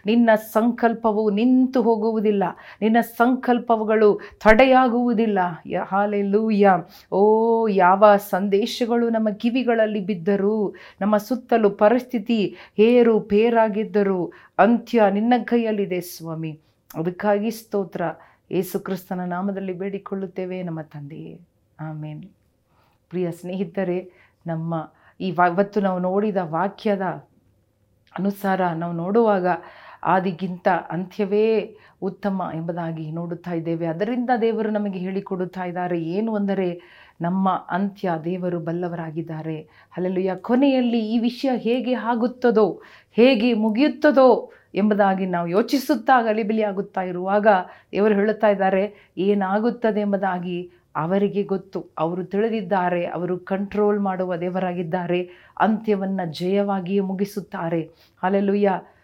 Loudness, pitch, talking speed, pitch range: -21 LUFS, 200 Hz, 90 wpm, 180-220 Hz